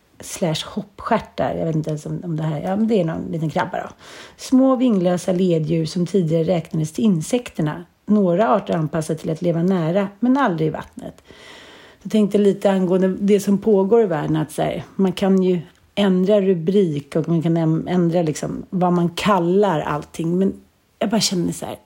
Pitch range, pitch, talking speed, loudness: 165-200 Hz, 180 Hz, 185 wpm, -19 LUFS